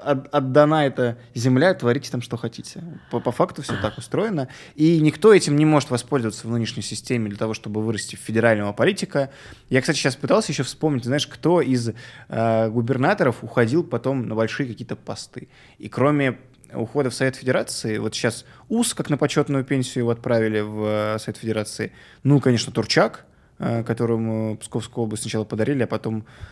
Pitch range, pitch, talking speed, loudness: 110-145 Hz, 125 Hz, 170 wpm, -22 LUFS